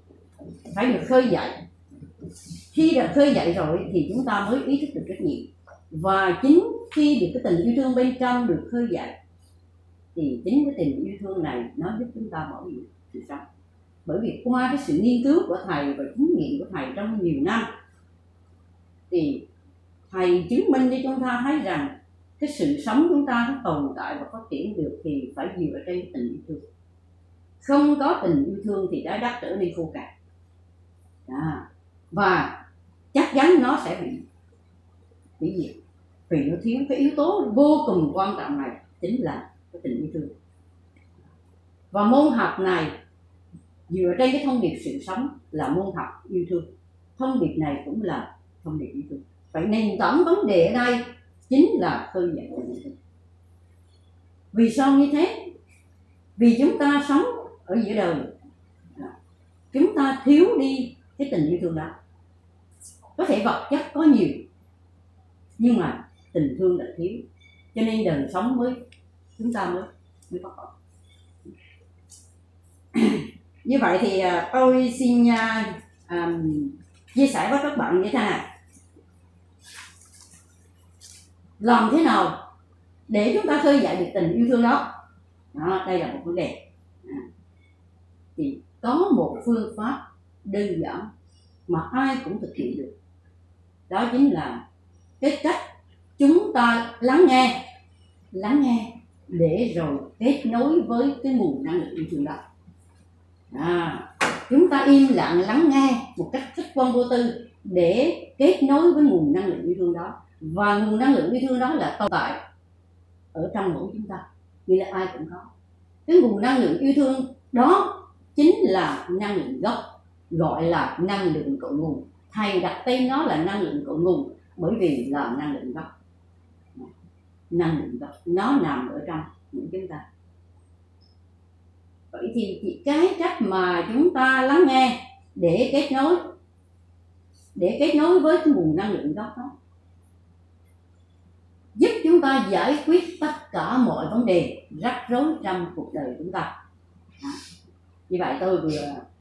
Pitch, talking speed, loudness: 180 Hz, 165 wpm, -23 LUFS